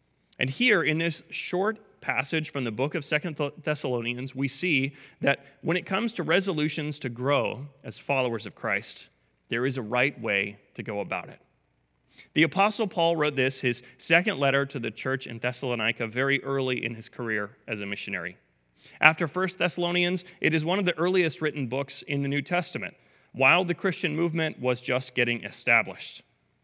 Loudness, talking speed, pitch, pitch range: -27 LUFS, 180 wpm, 140 Hz, 120-170 Hz